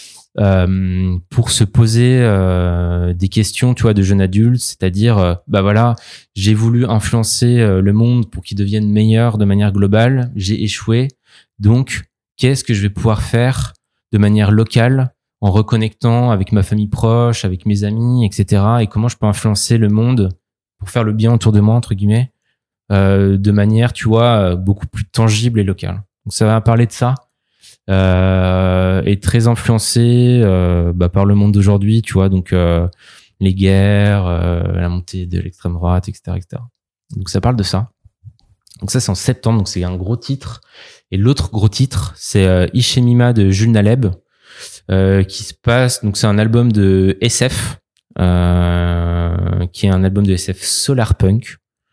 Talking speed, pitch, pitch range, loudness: 175 wpm, 105 Hz, 95-115 Hz, -14 LUFS